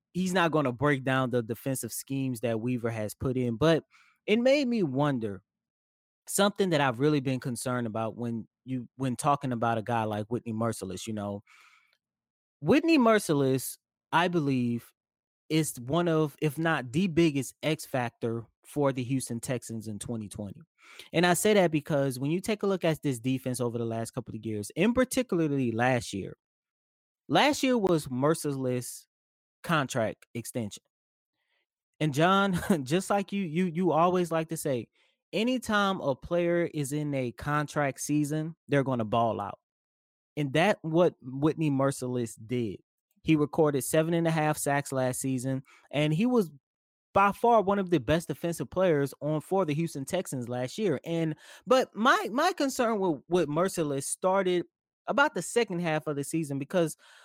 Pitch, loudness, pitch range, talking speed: 150 Hz, -28 LUFS, 125-175 Hz, 170 wpm